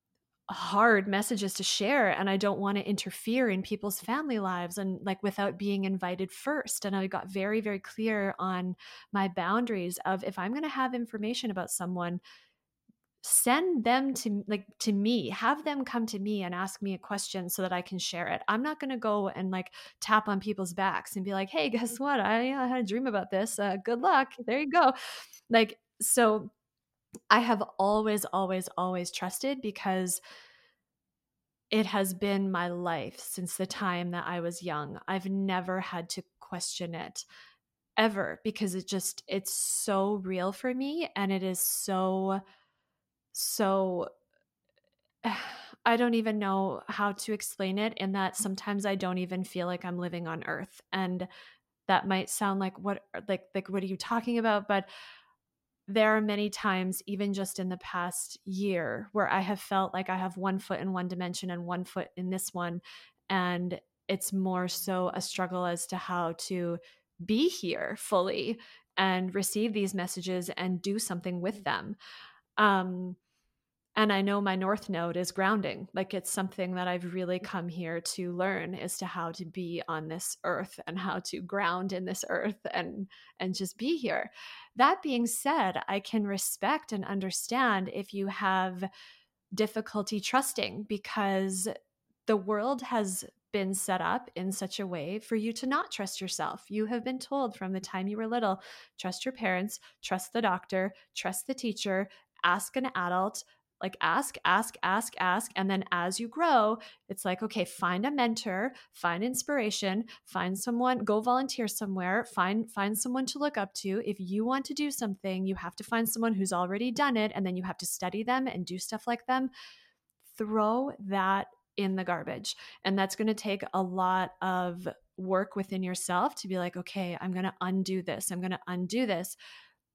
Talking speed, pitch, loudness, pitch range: 180 wpm, 195 Hz, -31 LUFS, 185-220 Hz